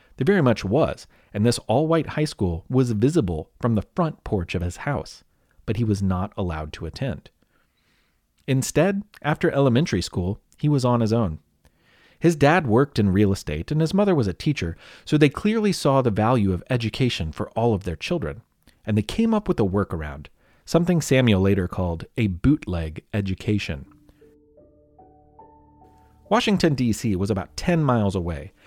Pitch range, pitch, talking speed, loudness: 85-145 Hz, 110 Hz, 170 wpm, -23 LUFS